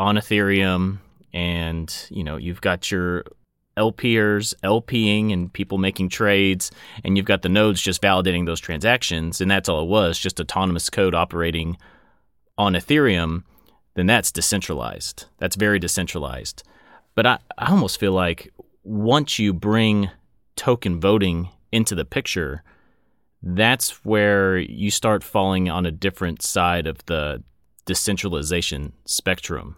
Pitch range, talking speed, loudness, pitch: 85-105 Hz, 135 wpm, -21 LUFS, 95 Hz